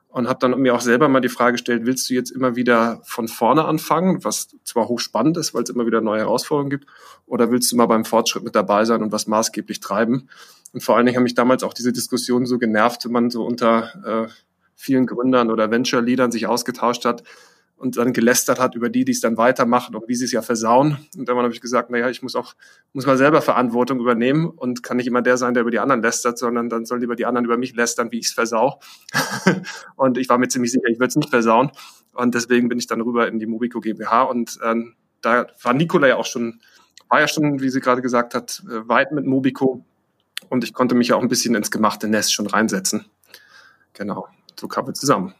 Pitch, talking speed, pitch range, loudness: 120 Hz, 240 wpm, 115-125 Hz, -19 LUFS